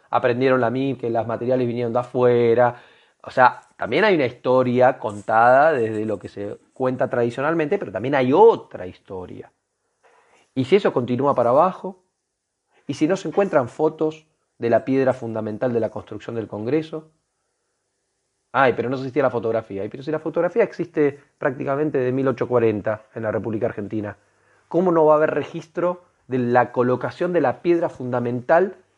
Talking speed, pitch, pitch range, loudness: 165 wpm, 130 Hz, 115-155 Hz, -21 LUFS